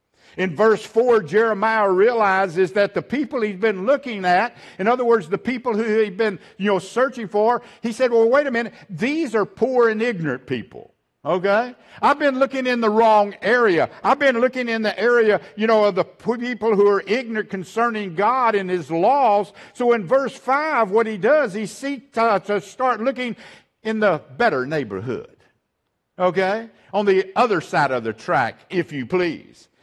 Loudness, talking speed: -20 LUFS, 185 wpm